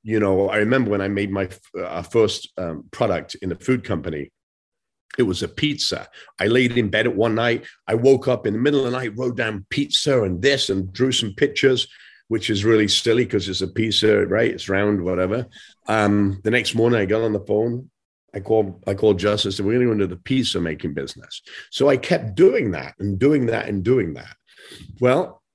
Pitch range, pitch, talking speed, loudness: 100-125 Hz, 110 Hz, 215 wpm, -20 LUFS